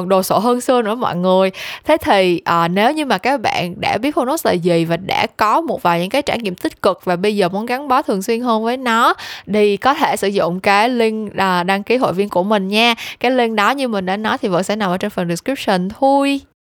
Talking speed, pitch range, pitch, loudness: 260 wpm, 190-245 Hz, 210 Hz, -16 LUFS